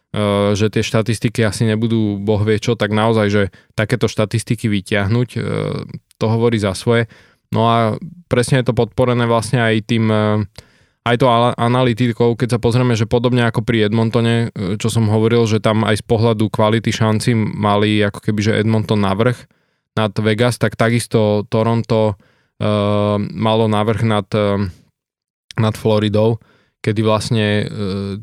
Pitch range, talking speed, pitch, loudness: 105-120 Hz, 145 wpm, 110 Hz, -16 LUFS